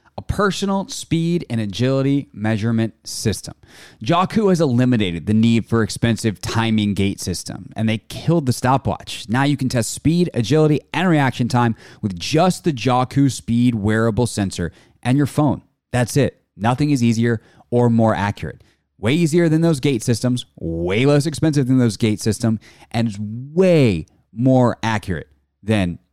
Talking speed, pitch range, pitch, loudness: 155 wpm, 110-145 Hz, 120 Hz, -19 LUFS